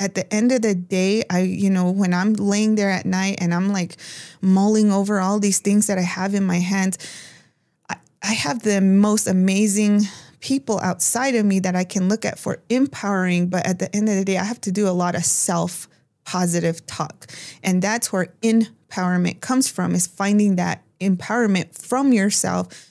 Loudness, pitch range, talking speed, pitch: -20 LUFS, 180-210 Hz, 195 wpm, 190 Hz